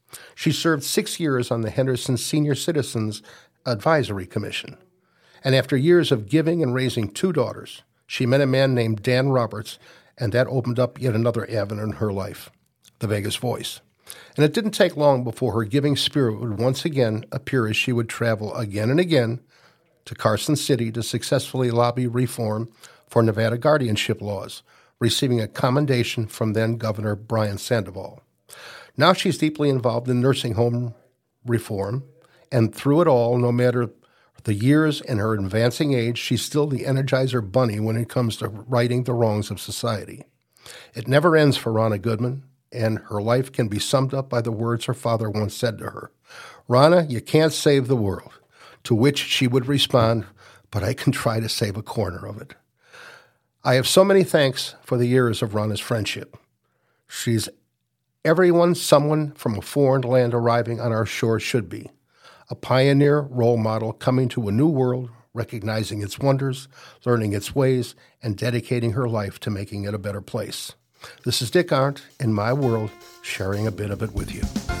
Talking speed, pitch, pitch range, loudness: 175 wpm, 120 Hz, 110-135 Hz, -22 LUFS